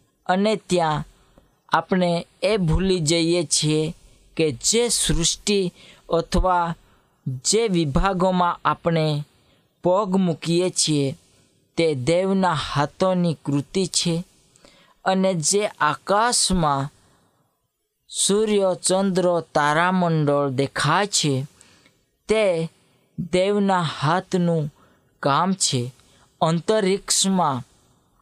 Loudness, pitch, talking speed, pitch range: -21 LUFS, 170 Hz, 75 wpm, 150-185 Hz